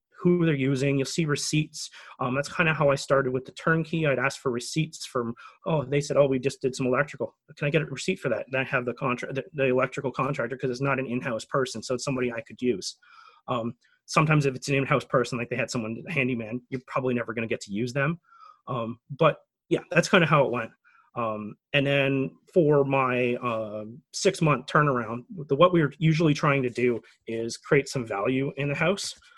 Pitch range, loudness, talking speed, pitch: 125-155 Hz, -26 LUFS, 225 wpm, 135 Hz